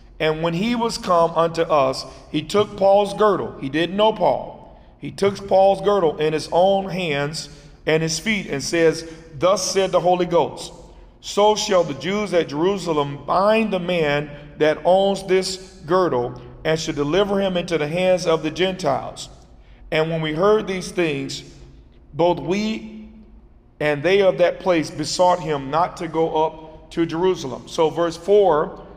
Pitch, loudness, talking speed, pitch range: 170 Hz, -20 LUFS, 165 wpm, 155-190 Hz